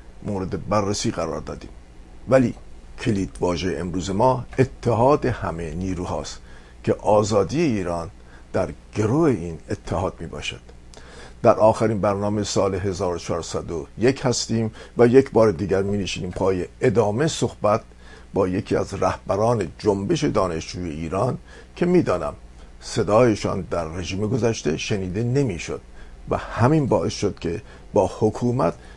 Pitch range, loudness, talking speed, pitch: 80-115 Hz, -22 LUFS, 120 wpm, 95 Hz